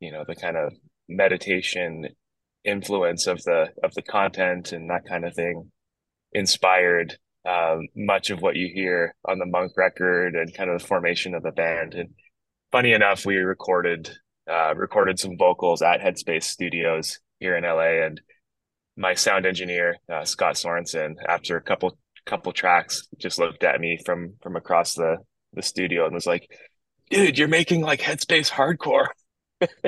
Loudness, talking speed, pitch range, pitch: -23 LUFS, 165 wpm, 85-95 Hz, 90 Hz